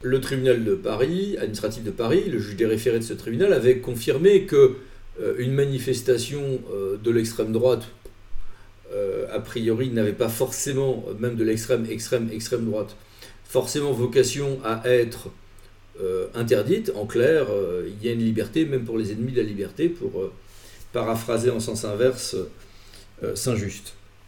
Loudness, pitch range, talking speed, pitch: -24 LUFS, 110-135 Hz, 145 wpm, 120 Hz